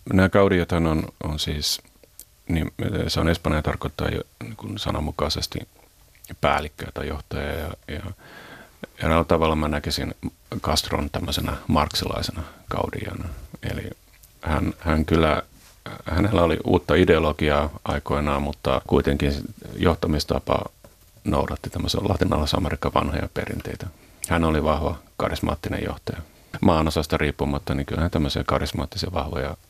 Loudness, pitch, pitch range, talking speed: -24 LUFS, 80 Hz, 75-90 Hz, 115 wpm